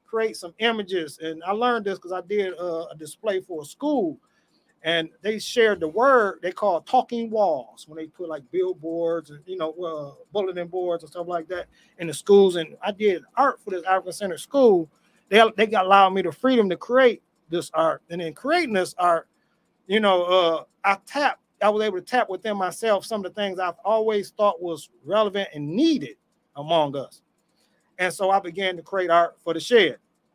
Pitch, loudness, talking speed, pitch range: 185 Hz, -23 LUFS, 205 wpm, 170-215 Hz